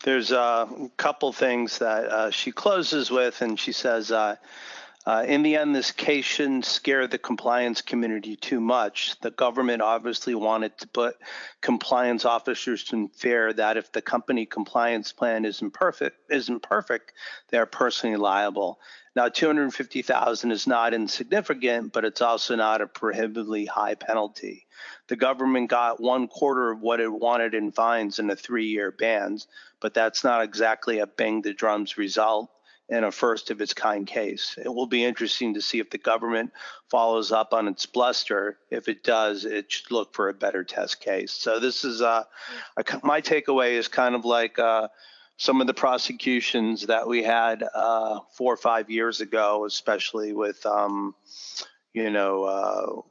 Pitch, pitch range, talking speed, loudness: 115 Hz, 110-120 Hz, 170 wpm, -25 LUFS